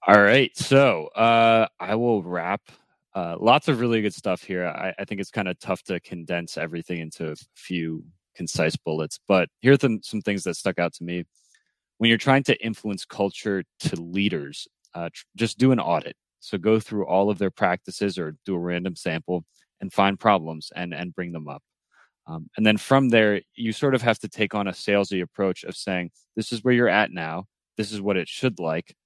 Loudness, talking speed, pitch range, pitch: -23 LUFS, 215 wpm, 90-110 Hz, 100 Hz